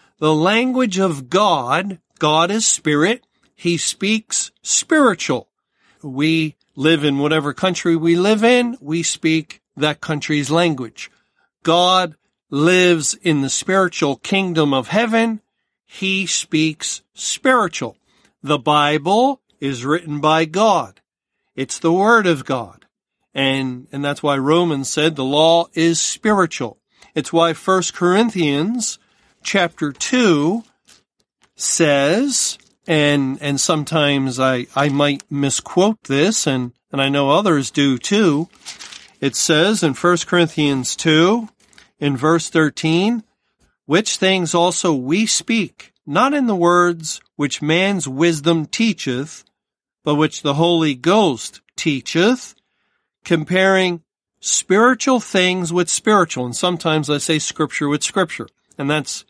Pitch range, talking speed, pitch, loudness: 145-190 Hz, 120 wpm, 165 Hz, -17 LUFS